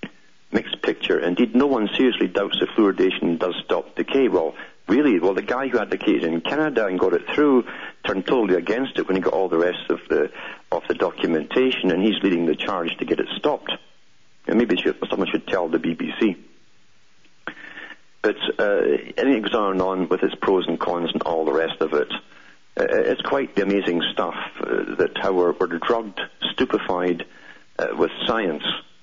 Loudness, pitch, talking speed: -22 LUFS, 155 Hz, 190 wpm